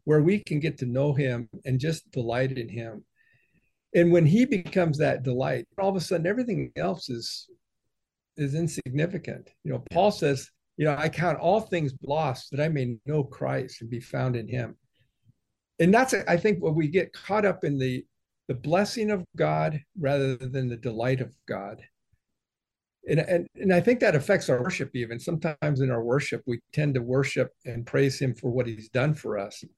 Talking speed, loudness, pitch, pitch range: 195 wpm, -27 LUFS, 145 Hz, 130-170 Hz